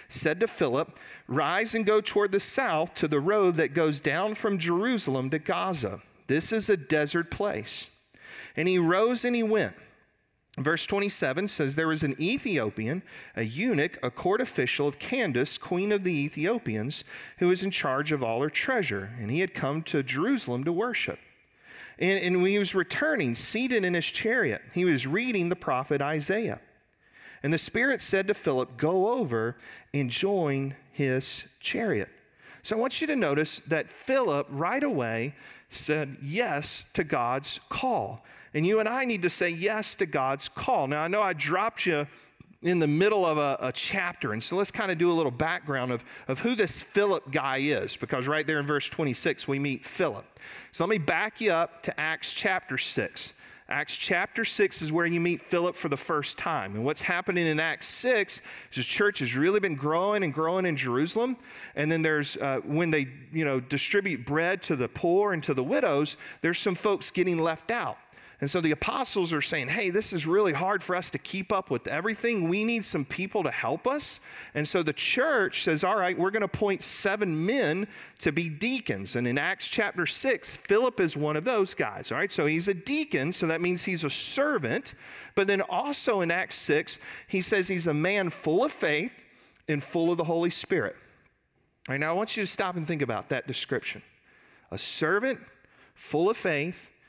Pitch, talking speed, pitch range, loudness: 170 Hz, 200 wpm, 145-200 Hz, -28 LUFS